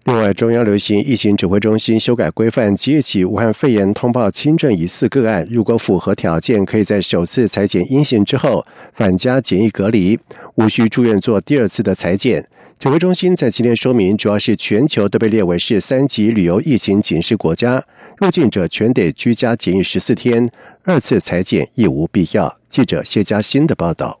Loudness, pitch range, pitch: -15 LUFS, 100-125 Hz, 110 Hz